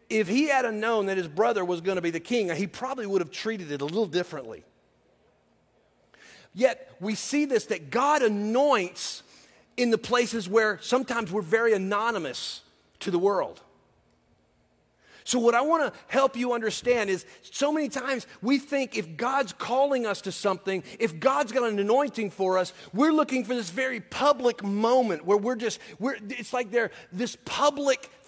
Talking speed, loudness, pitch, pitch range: 175 wpm, -26 LUFS, 230 Hz, 200-260 Hz